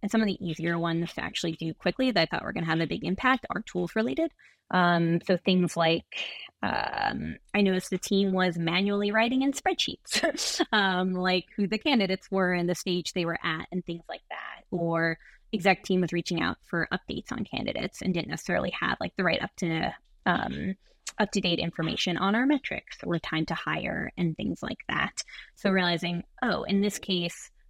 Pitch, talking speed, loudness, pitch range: 185 Hz, 205 wpm, -28 LUFS, 170-205 Hz